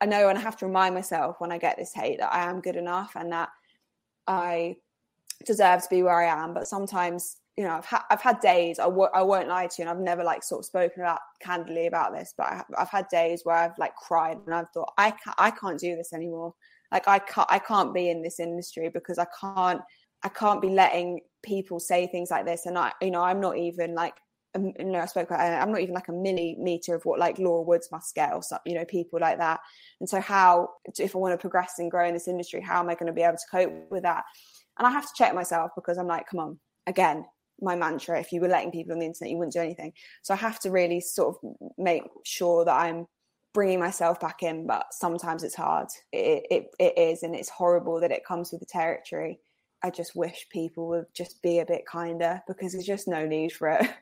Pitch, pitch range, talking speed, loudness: 175 Hz, 170-185 Hz, 255 wpm, -27 LUFS